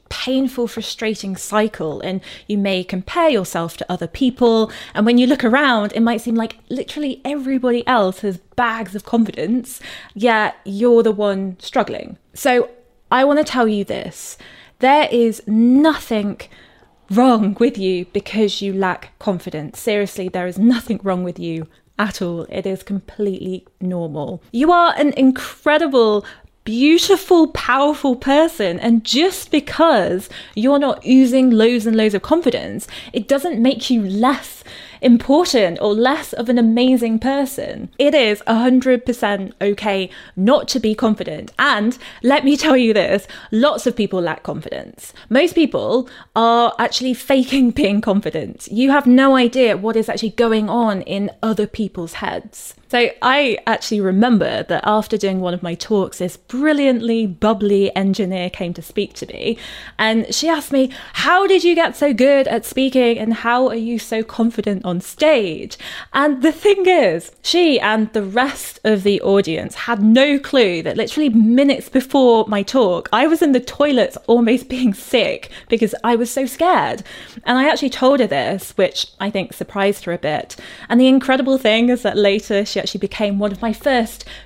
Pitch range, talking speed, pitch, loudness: 205-265 Hz, 165 wpm, 230 Hz, -17 LUFS